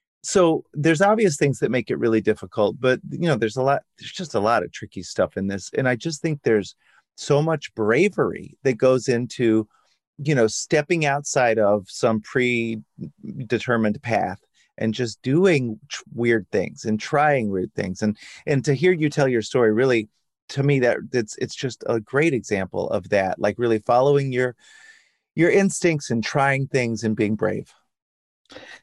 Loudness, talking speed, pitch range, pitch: -22 LUFS, 175 wpm, 110-150 Hz, 130 Hz